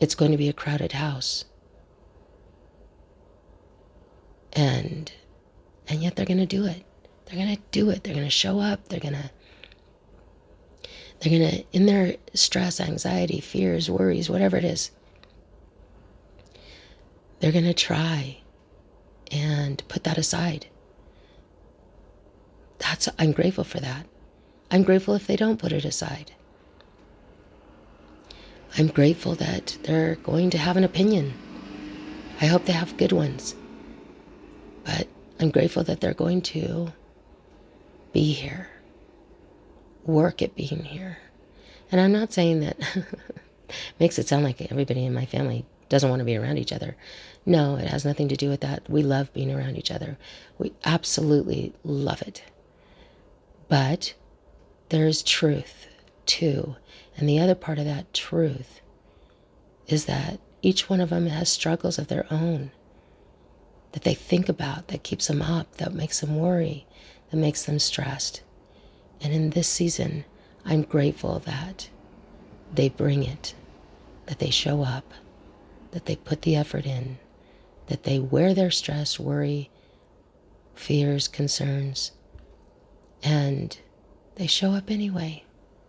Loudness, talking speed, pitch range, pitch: -25 LUFS, 140 wpm, 100-170 Hz, 150 Hz